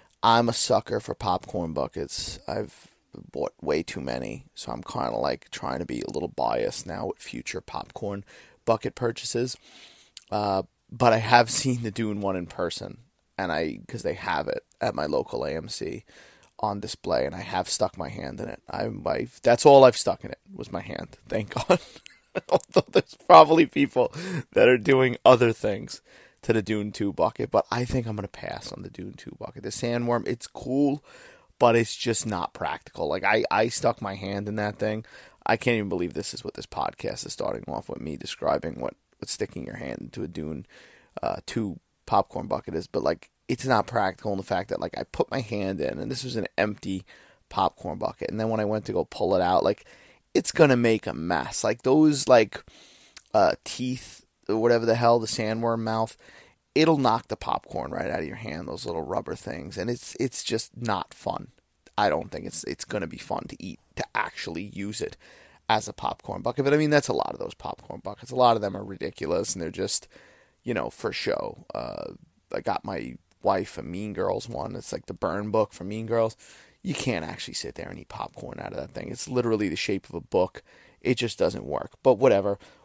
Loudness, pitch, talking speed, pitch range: -26 LUFS, 115 Hz, 215 wpm, 105-125 Hz